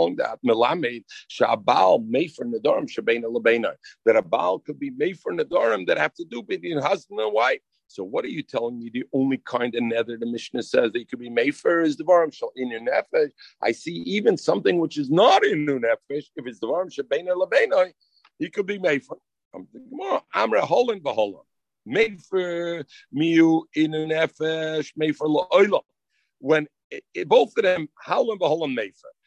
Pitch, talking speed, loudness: 160 Hz, 185 wpm, -23 LUFS